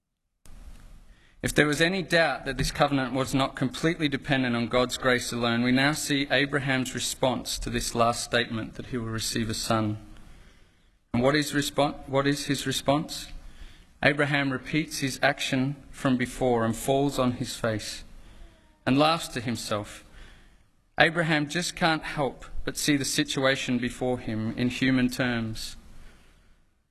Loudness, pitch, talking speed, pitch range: -26 LUFS, 130 Hz, 150 wpm, 115-140 Hz